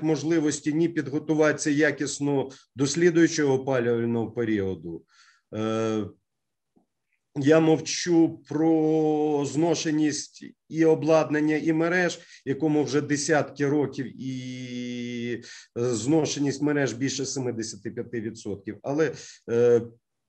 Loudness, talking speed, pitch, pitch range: -25 LUFS, 75 wpm, 145 Hz, 120-155 Hz